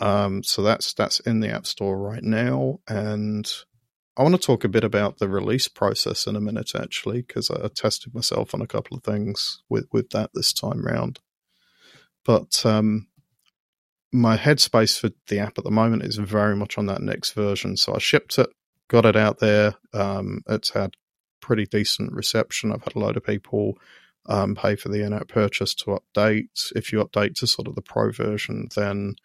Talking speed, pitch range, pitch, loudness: 195 wpm, 100-115 Hz, 105 Hz, -23 LUFS